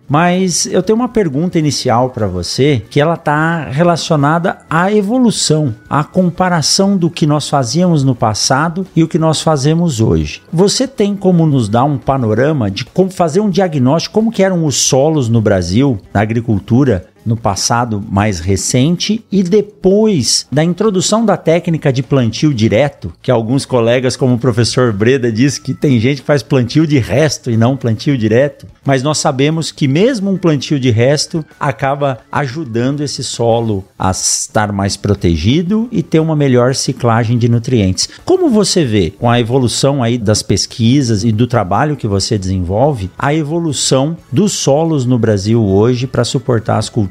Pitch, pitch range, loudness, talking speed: 140 Hz, 115-165 Hz, -13 LUFS, 170 wpm